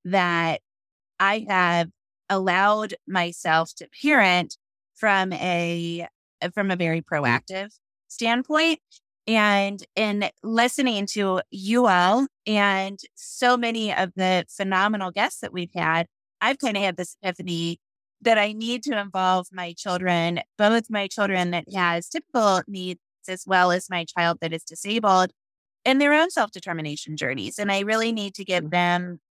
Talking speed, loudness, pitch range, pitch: 145 wpm, -23 LUFS, 175-215 Hz, 190 Hz